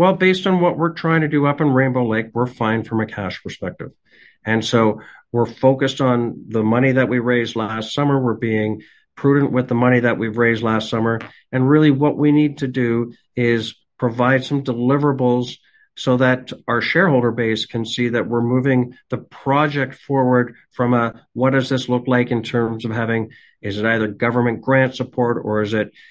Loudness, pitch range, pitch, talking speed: -18 LUFS, 115-135 Hz, 125 Hz, 195 wpm